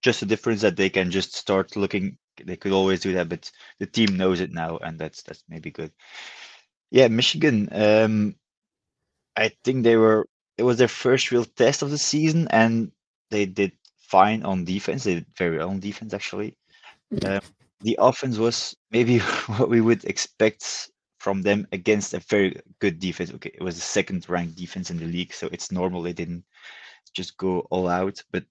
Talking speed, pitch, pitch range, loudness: 190 wpm, 100 Hz, 90-115 Hz, -23 LUFS